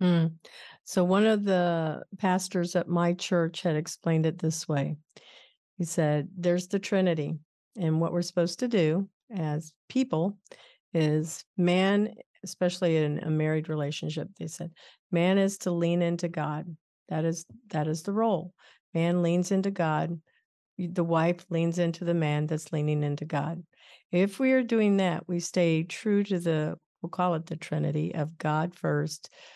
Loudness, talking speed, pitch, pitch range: -28 LUFS, 160 wpm, 170 Hz, 155-185 Hz